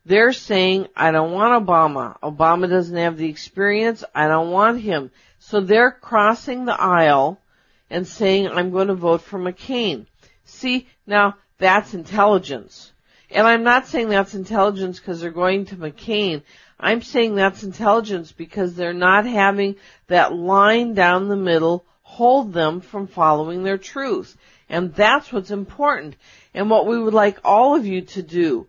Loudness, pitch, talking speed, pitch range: -18 LUFS, 195 Hz, 160 wpm, 175-220 Hz